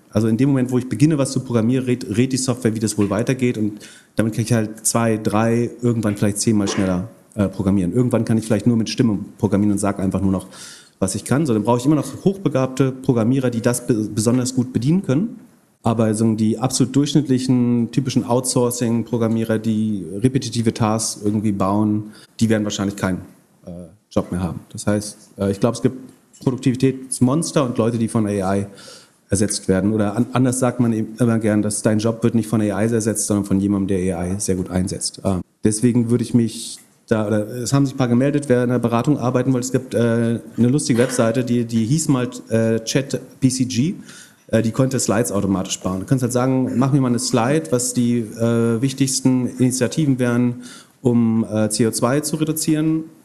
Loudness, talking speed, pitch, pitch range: -19 LUFS, 200 wpm, 115 Hz, 105-130 Hz